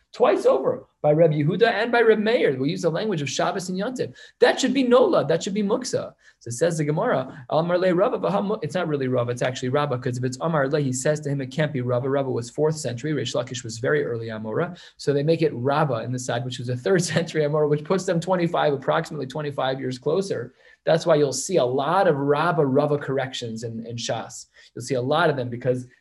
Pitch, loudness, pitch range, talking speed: 150 Hz, -23 LUFS, 130-175 Hz, 235 wpm